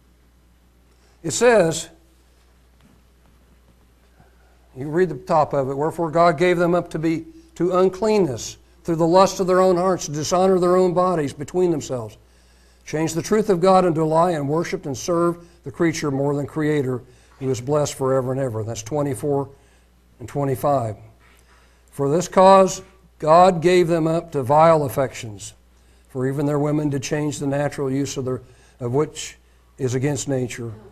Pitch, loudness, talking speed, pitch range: 140 Hz, -20 LUFS, 165 wpm, 110-170 Hz